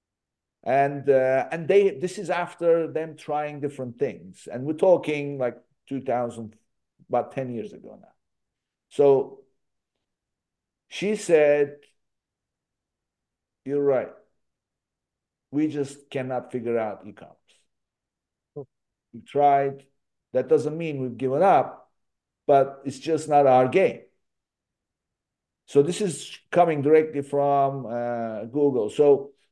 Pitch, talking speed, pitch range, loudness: 140 Hz, 115 wpm, 125-155 Hz, -24 LUFS